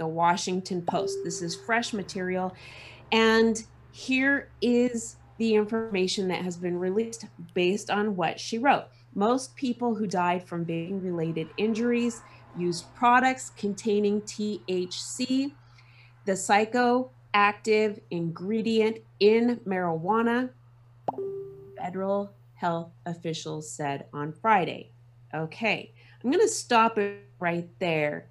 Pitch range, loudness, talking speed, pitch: 165-225 Hz, -27 LUFS, 110 wpm, 190 Hz